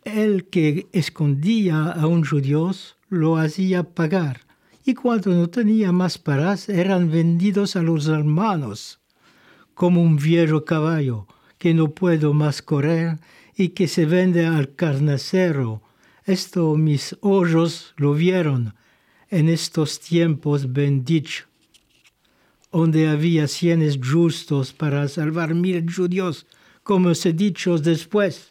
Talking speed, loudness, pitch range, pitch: 120 wpm, -20 LUFS, 150-180 Hz, 165 Hz